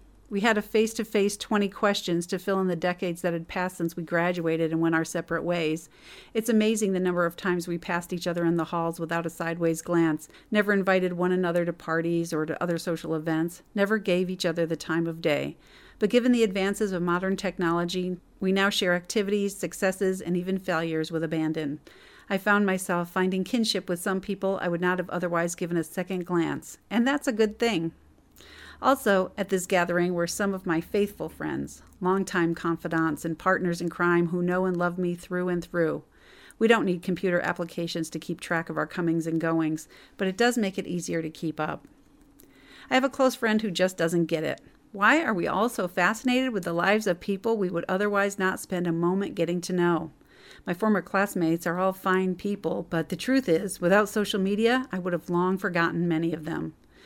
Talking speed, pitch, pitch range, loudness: 210 wpm, 180 Hz, 170-200 Hz, -27 LUFS